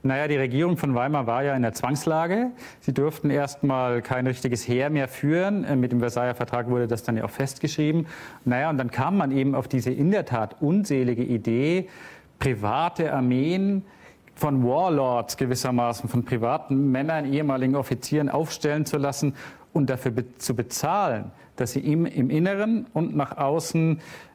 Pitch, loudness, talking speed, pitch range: 135 Hz, -25 LUFS, 165 wpm, 125-155 Hz